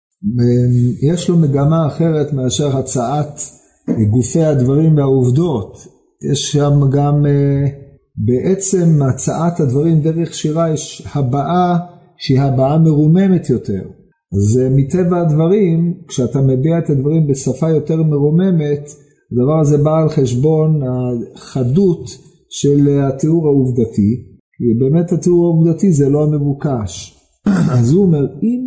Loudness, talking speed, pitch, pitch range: -14 LUFS, 110 wpm, 145 Hz, 130-165 Hz